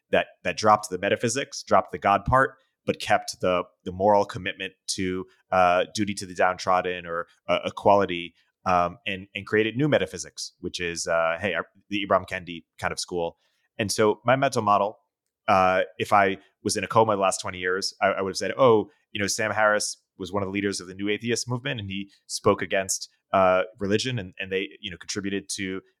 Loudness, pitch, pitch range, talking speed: -25 LUFS, 100 Hz, 95-105 Hz, 210 wpm